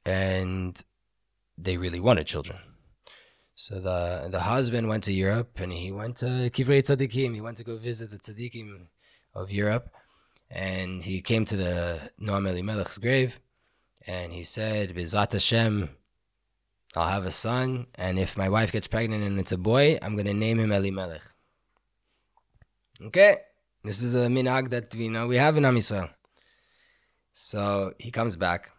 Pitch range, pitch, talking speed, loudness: 95-120 Hz, 105 Hz, 155 wpm, -26 LUFS